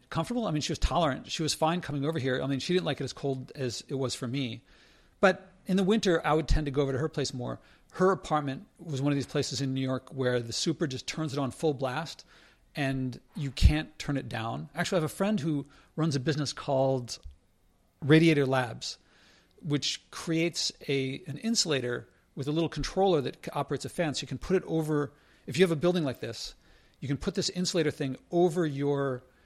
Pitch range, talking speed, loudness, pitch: 130-165 Hz, 225 wpm, -30 LUFS, 145 Hz